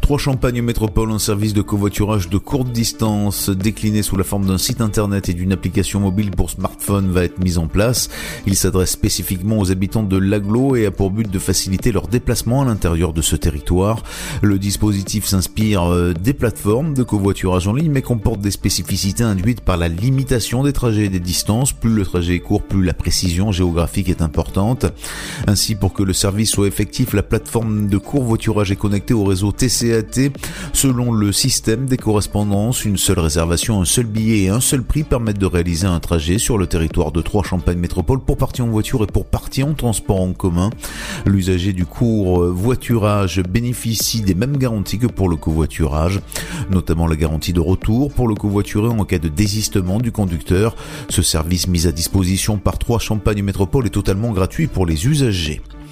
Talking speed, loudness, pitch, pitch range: 185 wpm, -18 LUFS, 100 Hz, 95-115 Hz